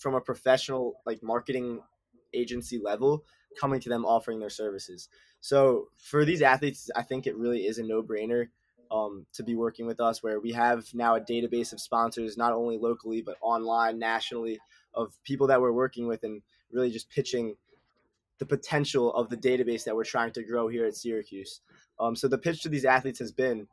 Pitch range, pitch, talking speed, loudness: 115-130 Hz, 120 Hz, 190 wpm, -29 LUFS